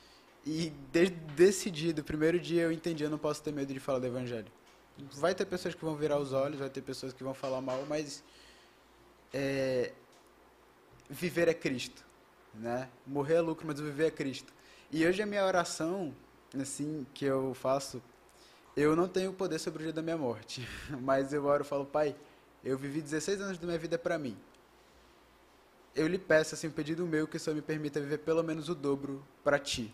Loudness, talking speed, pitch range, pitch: -34 LUFS, 195 wpm, 135-165 Hz, 150 Hz